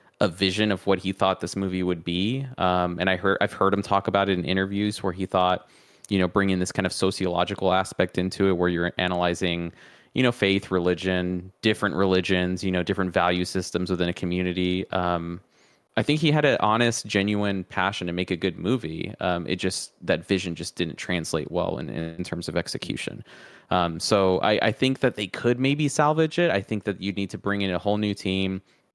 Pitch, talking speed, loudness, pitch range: 95 Hz, 215 wpm, -25 LUFS, 90-100 Hz